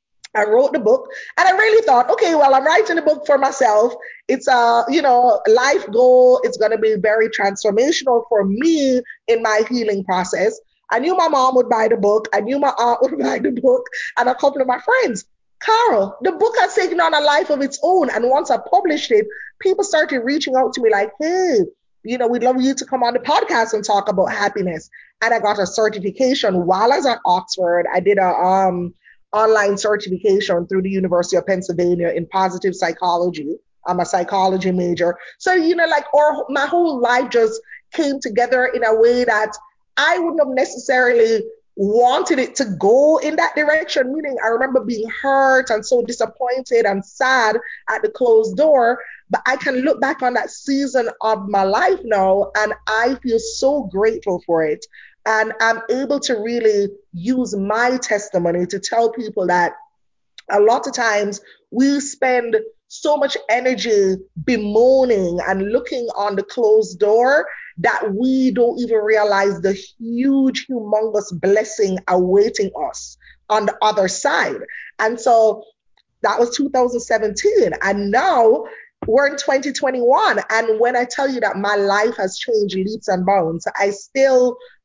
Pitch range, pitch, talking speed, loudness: 205-280 Hz, 235 Hz, 175 wpm, -17 LUFS